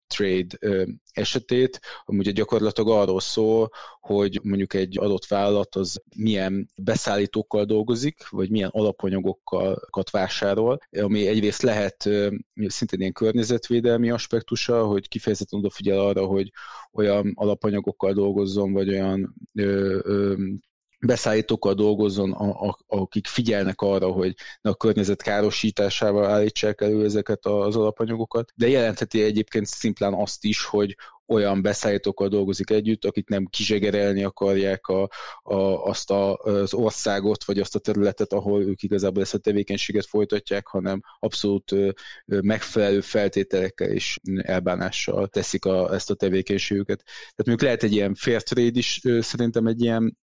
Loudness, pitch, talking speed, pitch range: -23 LUFS, 100 Hz, 130 wpm, 100-110 Hz